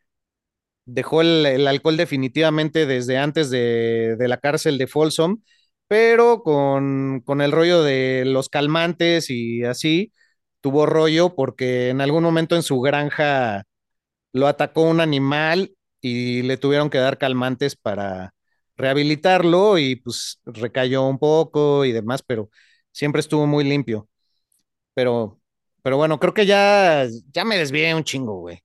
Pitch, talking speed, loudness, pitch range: 145 Hz, 140 wpm, -19 LUFS, 130-160 Hz